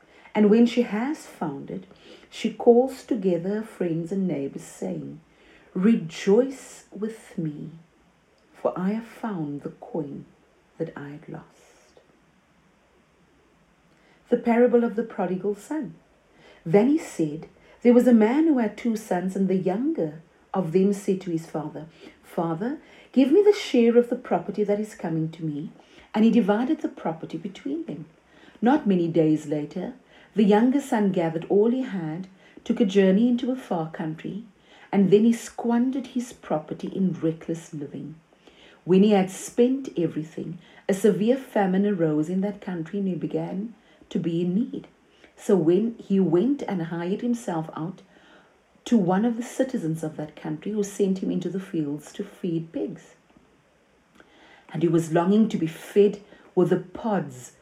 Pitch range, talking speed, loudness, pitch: 170-235 Hz, 160 wpm, -24 LUFS, 200 Hz